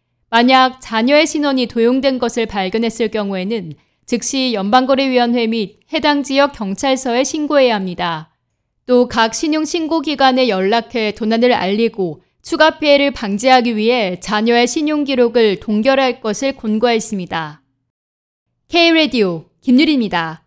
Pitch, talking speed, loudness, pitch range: 235 Hz, 305 characters per minute, -15 LUFS, 205-270 Hz